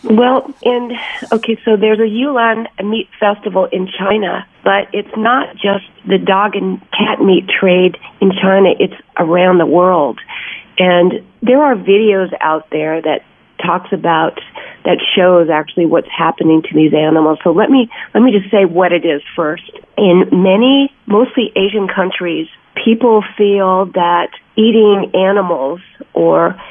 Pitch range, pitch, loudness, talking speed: 175-220 Hz, 195 Hz, -12 LUFS, 150 wpm